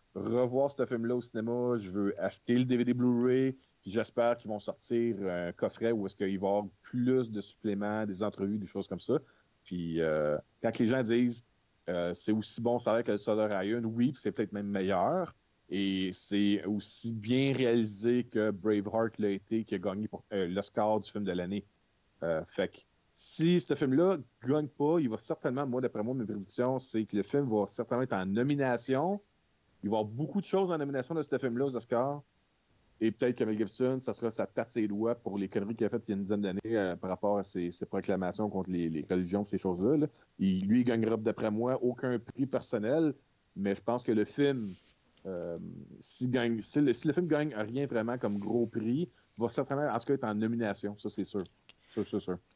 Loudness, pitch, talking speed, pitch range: -33 LUFS, 115 Hz, 220 wpm, 100-125 Hz